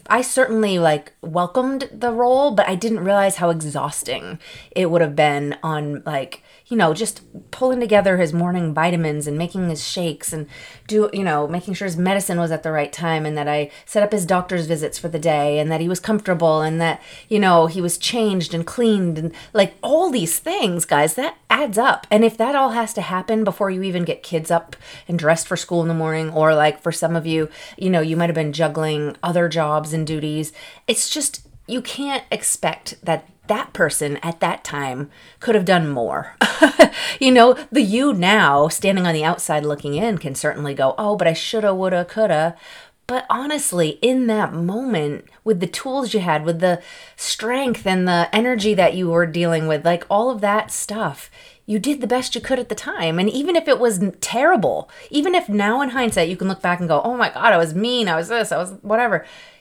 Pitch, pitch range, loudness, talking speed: 180 Hz, 160-220 Hz, -19 LUFS, 215 wpm